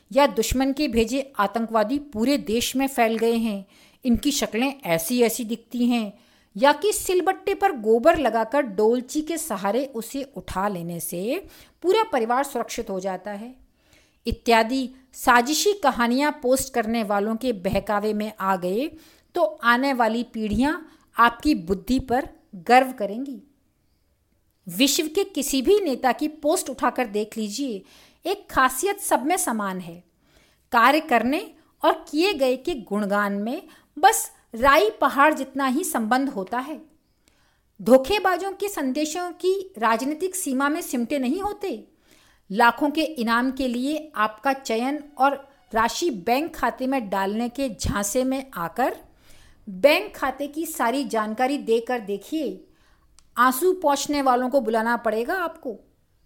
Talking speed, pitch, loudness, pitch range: 140 wpm, 260 Hz, -23 LUFS, 225-295 Hz